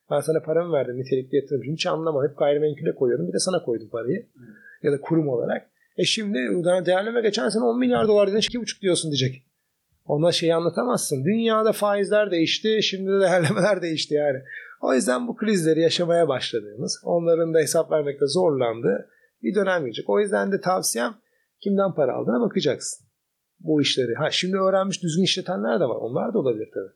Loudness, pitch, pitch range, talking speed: -23 LUFS, 175 Hz, 155-205 Hz, 175 wpm